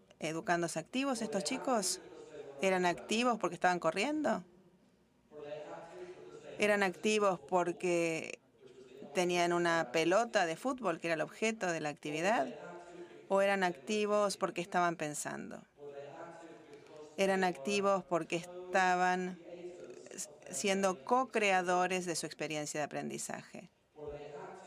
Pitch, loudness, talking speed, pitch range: 180 Hz, -34 LUFS, 100 wpm, 165-200 Hz